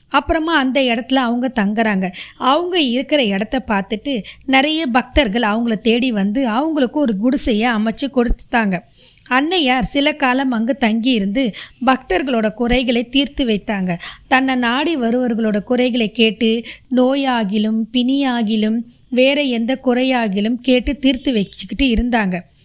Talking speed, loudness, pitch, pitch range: 110 wpm, -17 LUFS, 250 Hz, 225-265 Hz